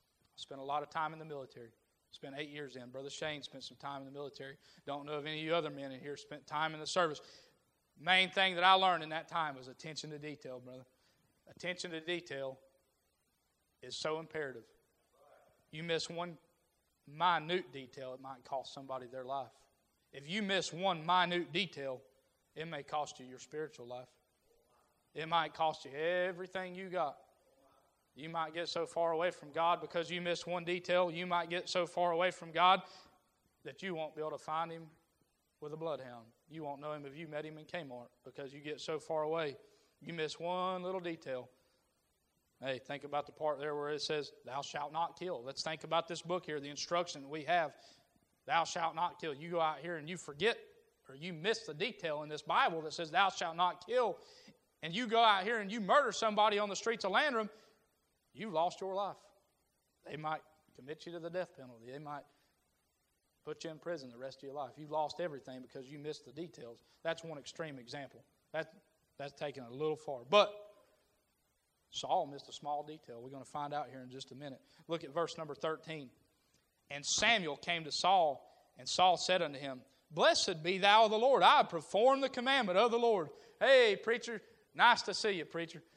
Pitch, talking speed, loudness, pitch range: 155 Hz, 205 wpm, -36 LUFS, 140-180 Hz